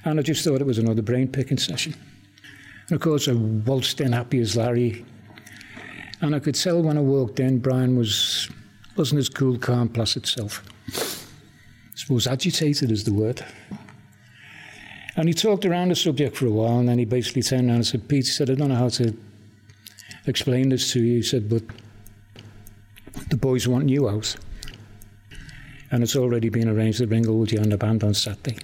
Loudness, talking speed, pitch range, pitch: -22 LUFS, 185 wpm, 110-135 Hz, 125 Hz